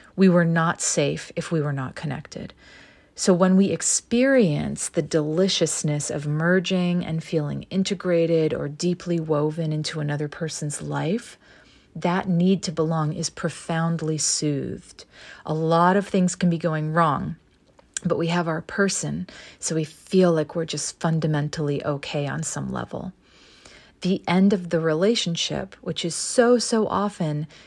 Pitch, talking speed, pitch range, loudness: 165 Hz, 150 wpm, 155-185 Hz, -23 LUFS